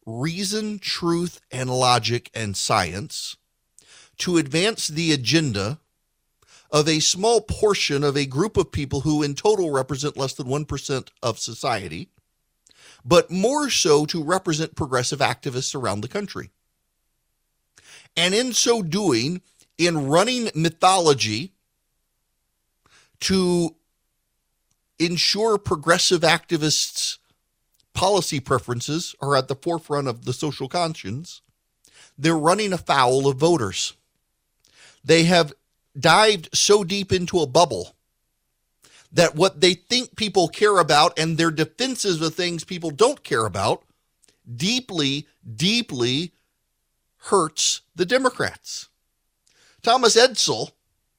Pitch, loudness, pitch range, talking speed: 165 Hz, -21 LUFS, 140-185 Hz, 110 wpm